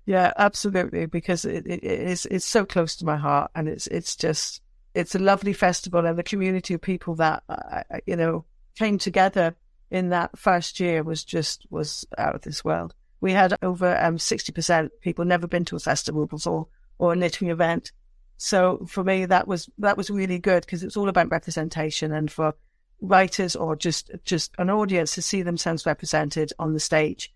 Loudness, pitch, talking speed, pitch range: -24 LUFS, 175 Hz, 195 wpm, 160-190 Hz